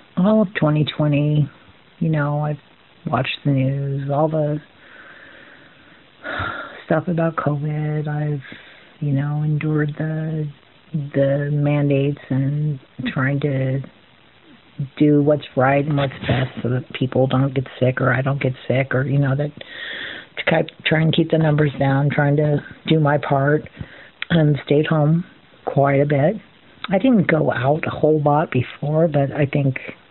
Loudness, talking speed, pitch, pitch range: -20 LUFS, 145 wpm, 145 Hz, 140-155 Hz